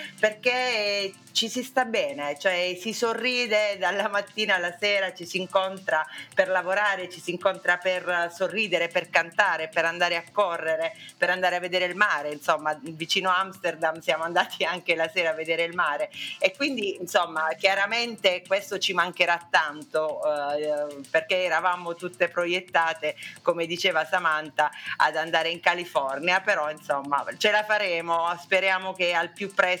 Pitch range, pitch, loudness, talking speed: 165-195 Hz, 180 Hz, -25 LUFS, 155 wpm